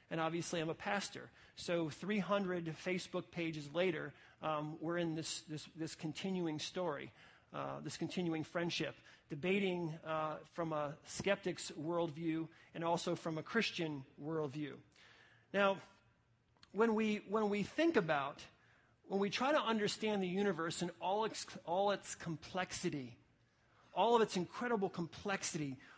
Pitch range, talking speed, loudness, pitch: 155-195 Hz, 135 wpm, -39 LUFS, 170 Hz